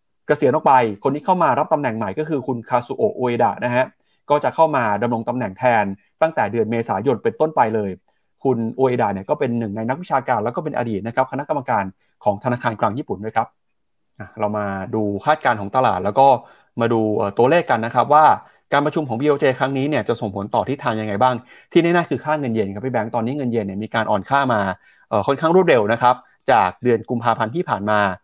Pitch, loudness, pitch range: 120 Hz, -19 LUFS, 110-135 Hz